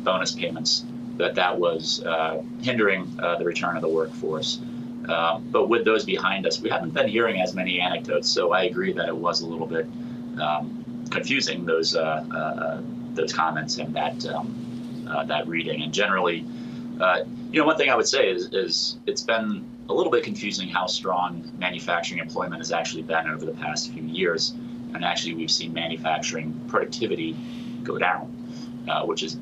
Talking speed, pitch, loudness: 180 wpm, 90 Hz, -25 LUFS